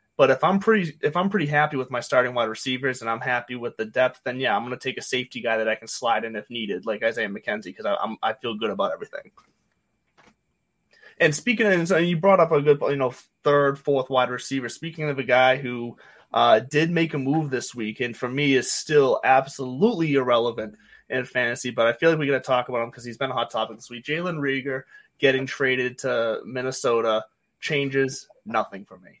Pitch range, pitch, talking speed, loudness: 120-145 Hz, 130 Hz, 220 wpm, -23 LUFS